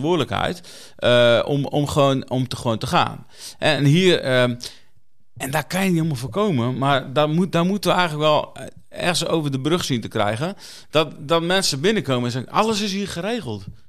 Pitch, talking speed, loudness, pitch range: 145 Hz, 195 wpm, -20 LUFS, 125-175 Hz